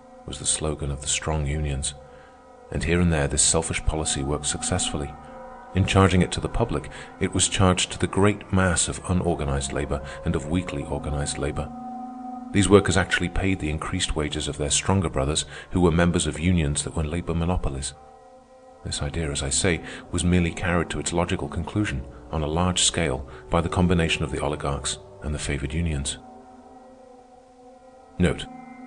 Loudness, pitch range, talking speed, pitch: -24 LUFS, 75-95 Hz, 175 wpm, 85 Hz